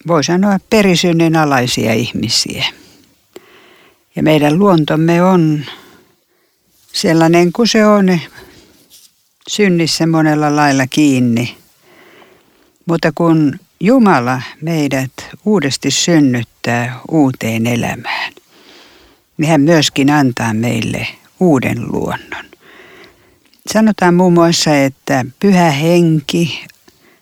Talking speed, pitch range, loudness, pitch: 85 wpm, 135-180 Hz, -13 LUFS, 160 Hz